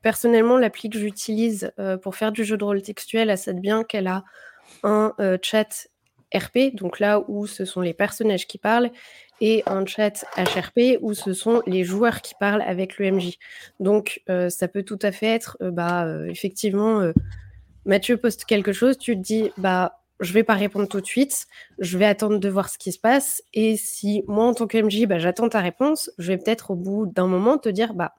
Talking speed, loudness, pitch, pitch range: 215 wpm, -22 LUFS, 210 Hz, 190-225 Hz